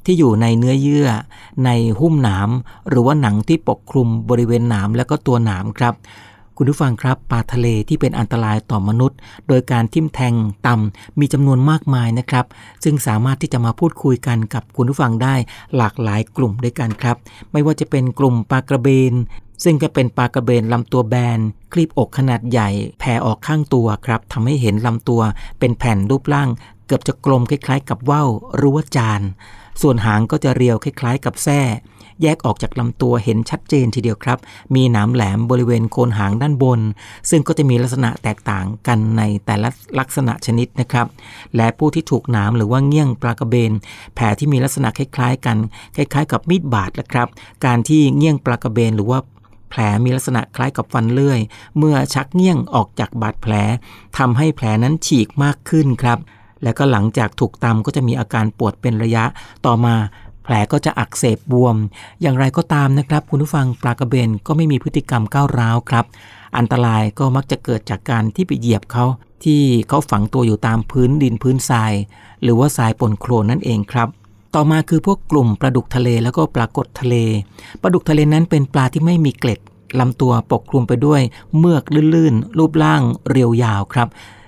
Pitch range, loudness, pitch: 110-140 Hz, -16 LUFS, 120 Hz